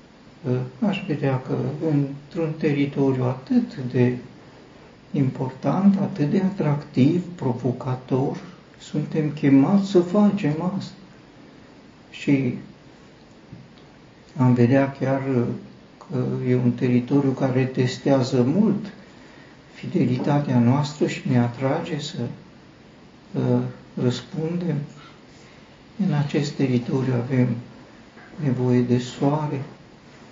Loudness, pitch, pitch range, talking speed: -23 LUFS, 140 Hz, 125-160 Hz, 85 wpm